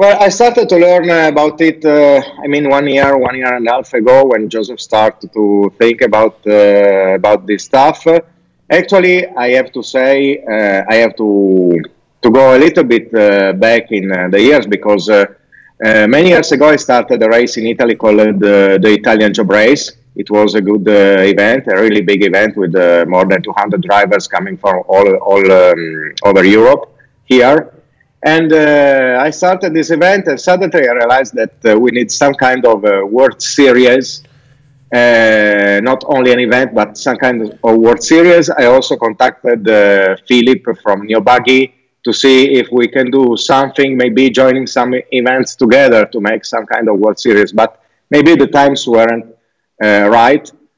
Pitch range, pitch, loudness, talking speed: 105-140 Hz, 125 Hz, -9 LUFS, 180 wpm